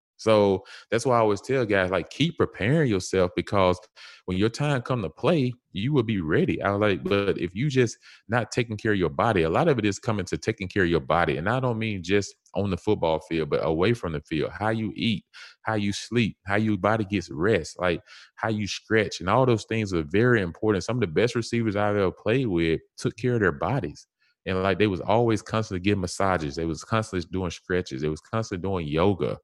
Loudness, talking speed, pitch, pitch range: -25 LUFS, 235 wpm, 105 Hz, 95-115 Hz